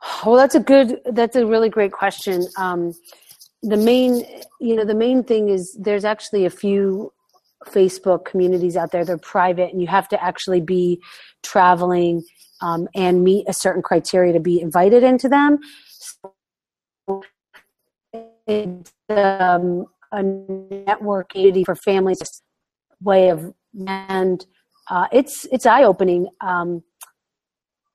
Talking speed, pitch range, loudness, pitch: 135 wpm, 180-215 Hz, -18 LUFS, 195 Hz